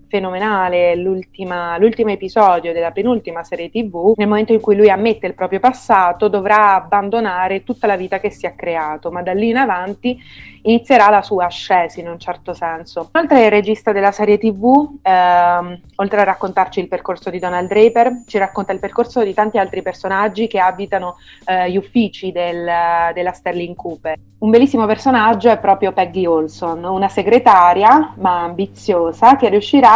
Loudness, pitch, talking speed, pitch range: -15 LUFS, 195 Hz, 165 wpm, 180-215 Hz